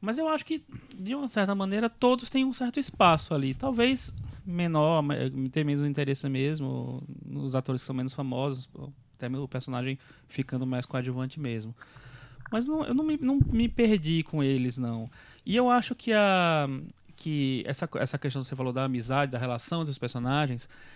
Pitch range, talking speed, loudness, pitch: 130-205 Hz, 175 wpm, -29 LUFS, 145 Hz